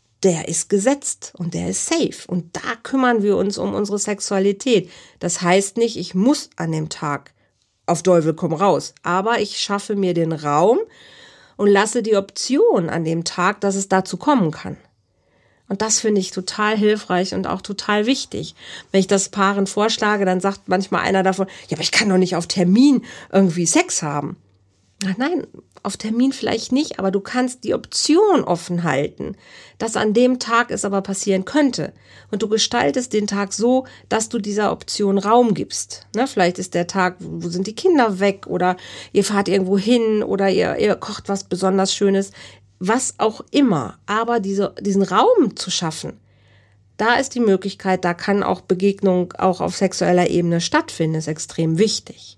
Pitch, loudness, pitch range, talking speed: 195 Hz, -19 LUFS, 180-220 Hz, 180 wpm